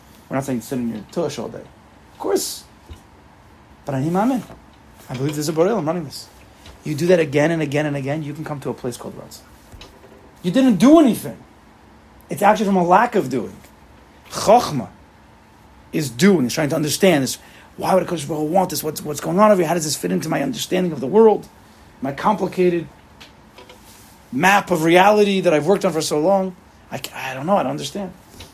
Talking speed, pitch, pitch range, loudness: 210 wpm, 160 Hz, 135-185 Hz, -19 LUFS